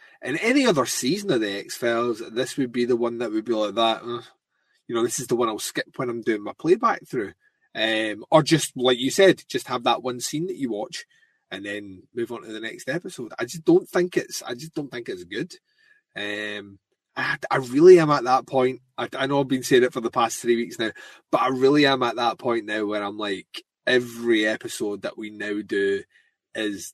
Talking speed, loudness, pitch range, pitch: 235 wpm, -23 LUFS, 110-160 Hz, 125 Hz